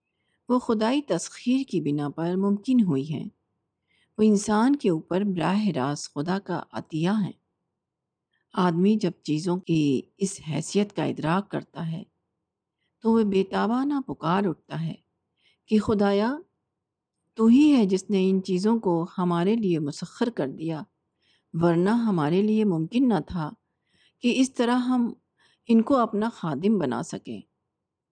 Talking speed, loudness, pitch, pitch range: 145 wpm, -25 LUFS, 195 Hz, 170-225 Hz